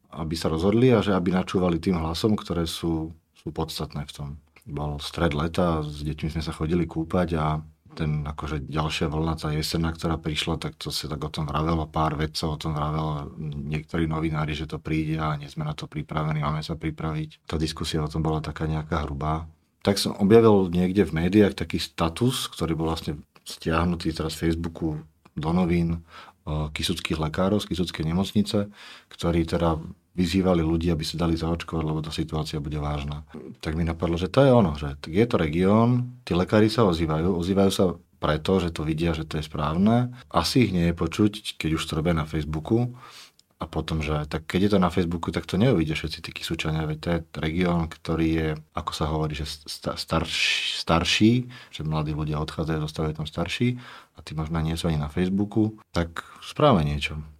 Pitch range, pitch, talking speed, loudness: 80-90 Hz, 80 Hz, 190 wpm, -25 LUFS